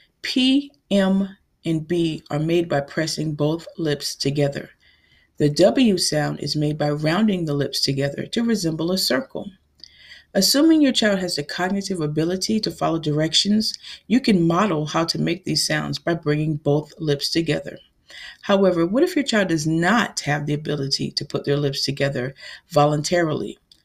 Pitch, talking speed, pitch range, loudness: 165 Hz, 160 wpm, 150-195 Hz, -21 LUFS